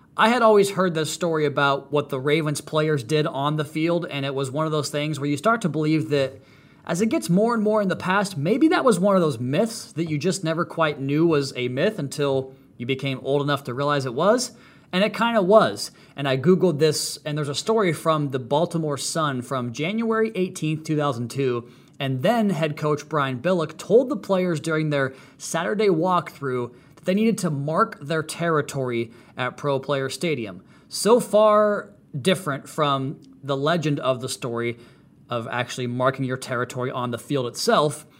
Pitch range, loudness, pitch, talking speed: 135-180 Hz, -23 LUFS, 150 Hz, 195 wpm